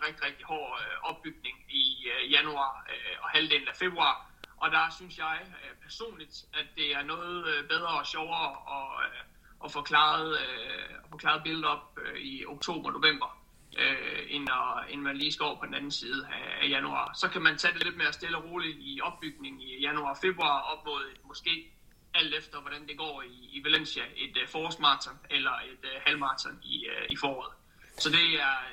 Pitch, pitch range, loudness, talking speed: 160 Hz, 145-225 Hz, -30 LUFS, 165 wpm